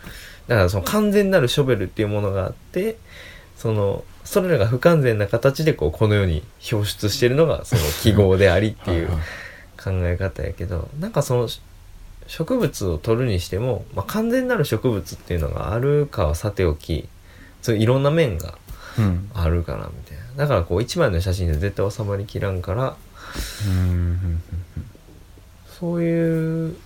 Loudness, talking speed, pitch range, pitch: -21 LUFS, 320 characters per minute, 90-120 Hz, 100 Hz